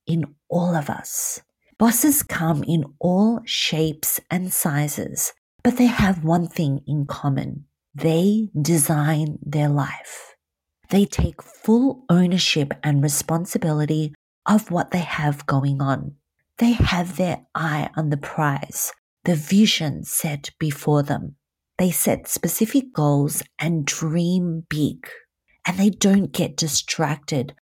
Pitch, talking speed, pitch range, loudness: 160 Hz, 125 wpm, 150-180 Hz, -21 LUFS